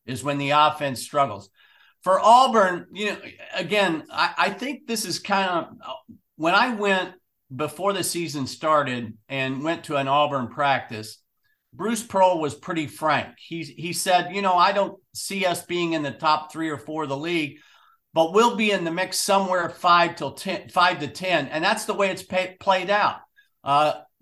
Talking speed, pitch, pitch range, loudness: 190 wpm, 175 Hz, 145-195 Hz, -23 LUFS